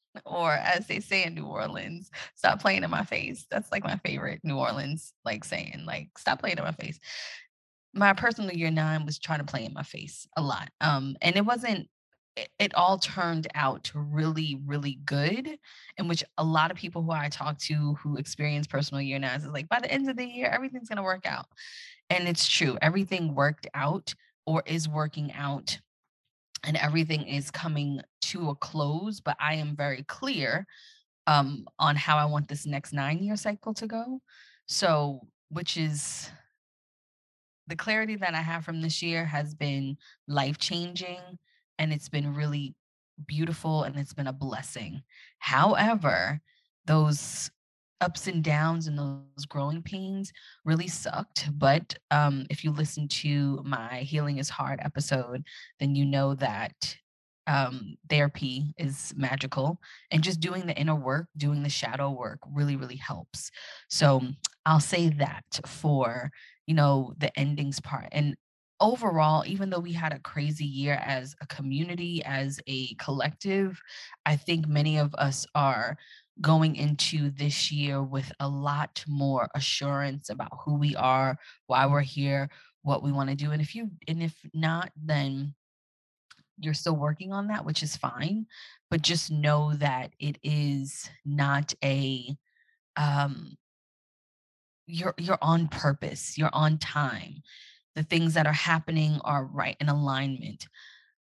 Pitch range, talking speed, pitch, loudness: 140-165 Hz, 160 wpm, 150 Hz, -29 LUFS